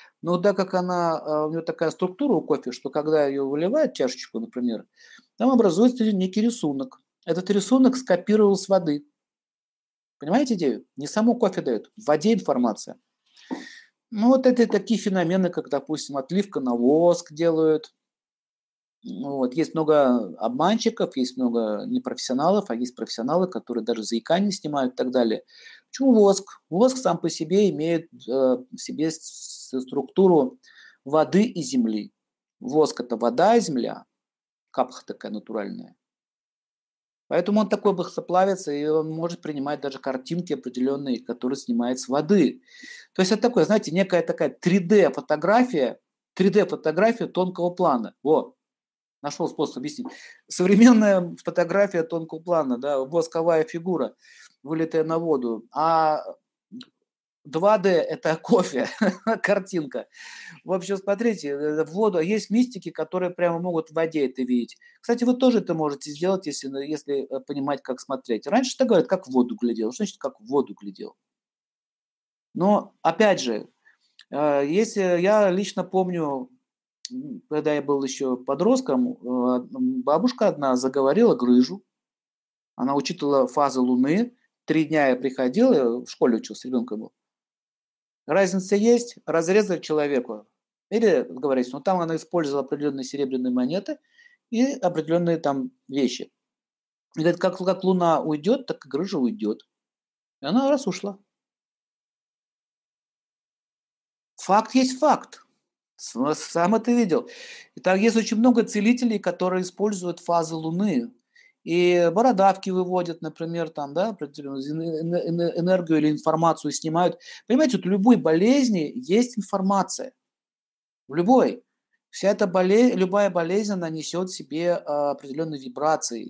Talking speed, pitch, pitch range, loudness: 130 wpm, 175 Hz, 145-215 Hz, -23 LUFS